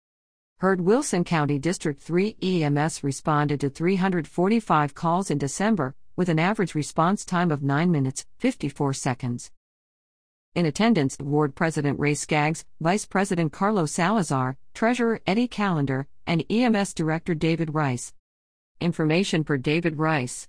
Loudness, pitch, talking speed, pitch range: -24 LUFS, 165 Hz, 130 wpm, 145-185 Hz